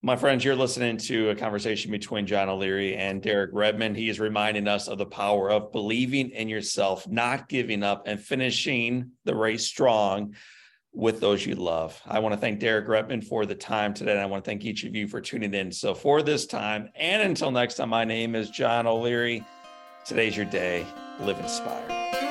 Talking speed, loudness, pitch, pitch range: 200 wpm, -26 LUFS, 110 Hz, 100-120 Hz